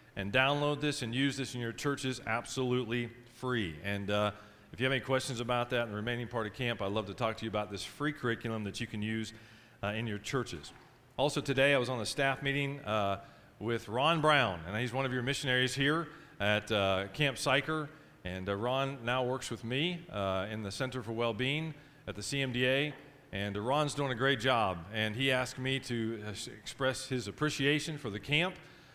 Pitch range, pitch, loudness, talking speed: 110-140 Hz, 125 Hz, -33 LUFS, 210 wpm